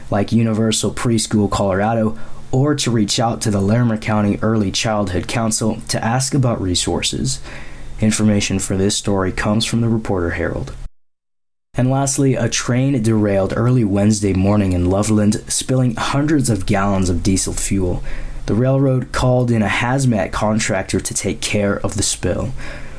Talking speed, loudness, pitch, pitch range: 150 wpm, -17 LUFS, 105 Hz, 95-115 Hz